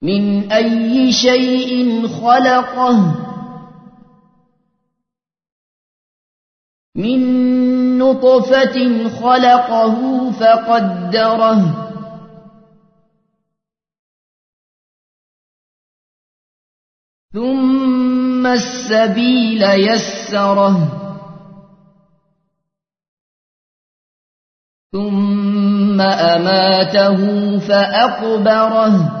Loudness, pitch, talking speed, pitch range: -13 LUFS, 220 Hz, 30 wpm, 195-245 Hz